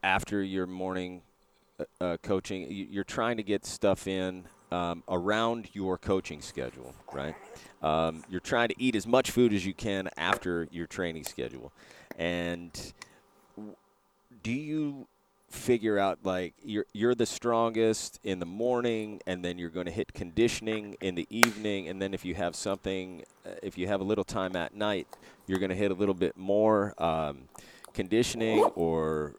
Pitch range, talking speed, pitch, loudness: 90-110 Hz, 165 wpm, 95 Hz, -31 LUFS